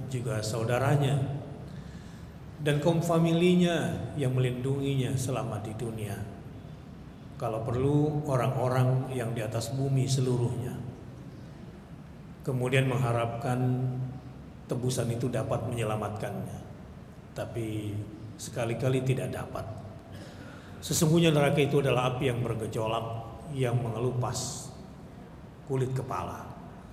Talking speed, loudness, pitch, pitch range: 85 wpm, -29 LUFS, 130 Hz, 115-135 Hz